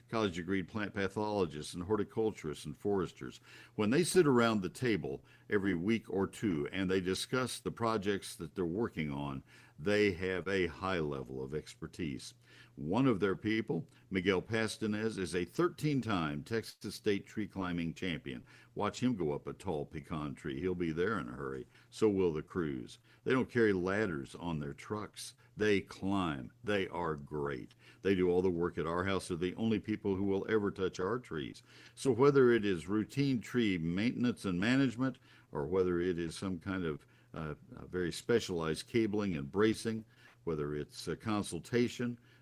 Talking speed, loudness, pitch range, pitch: 175 wpm, -35 LUFS, 85-110 Hz, 95 Hz